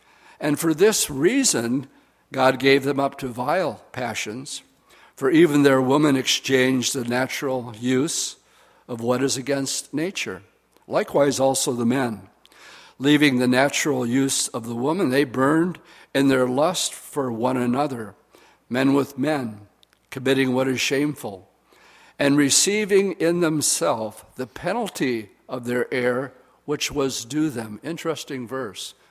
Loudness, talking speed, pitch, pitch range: -22 LUFS, 135 wpm, 135 Hz, 125-150 Hz